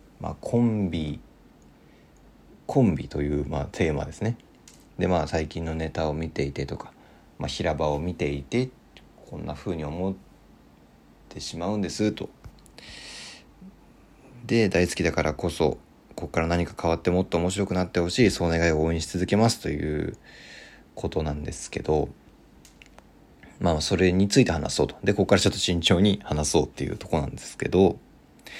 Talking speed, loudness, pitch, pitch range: 320 characters per minute, -26 LUFS, 85 Hz, 75-100 Hz